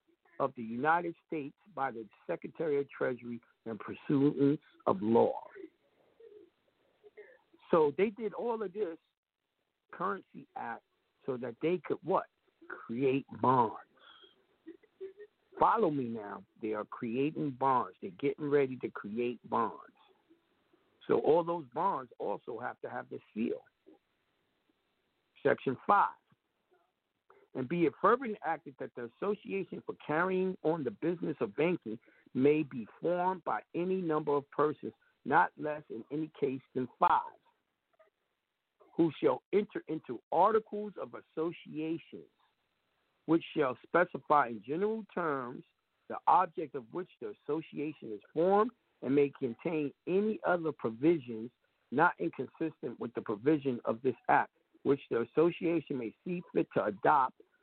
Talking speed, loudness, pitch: 130 wpm, -33 LUFS, 165 Hz